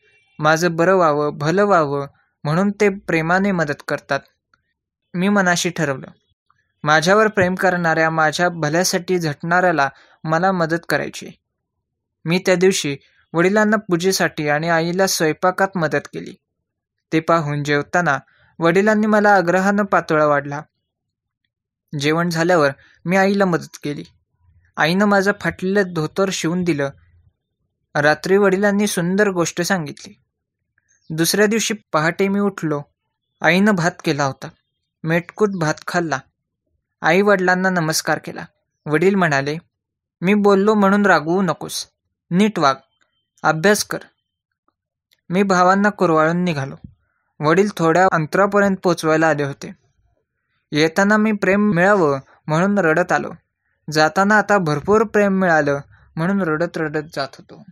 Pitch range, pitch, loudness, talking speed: 150-195 Hz, 170 Hz, -17 LUFS, 115 wpm